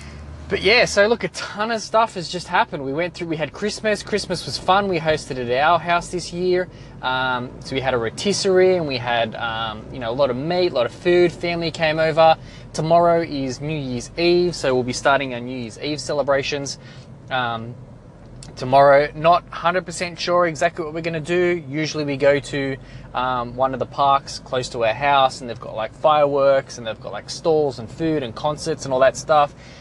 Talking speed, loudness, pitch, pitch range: 215 wpm, -20 LUFS, 145 Hz, 130-170 Hz